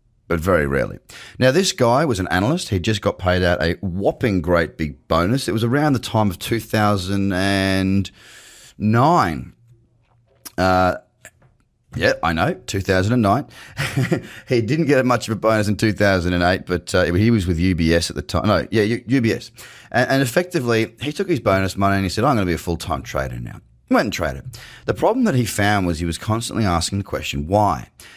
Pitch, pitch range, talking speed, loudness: 105 Hz, 90-120 Hz, 190 wpm, -19 LUFS